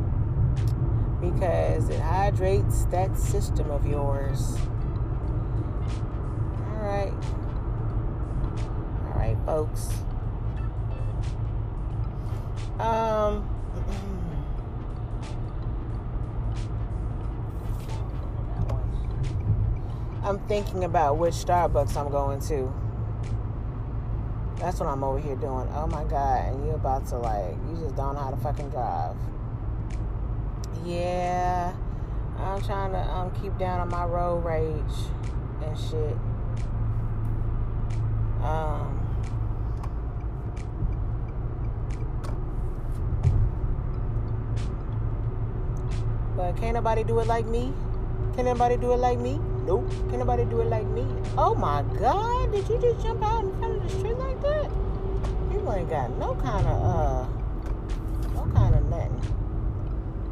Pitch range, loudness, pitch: 110-120 Hz, -28 LUFS, 115 Hz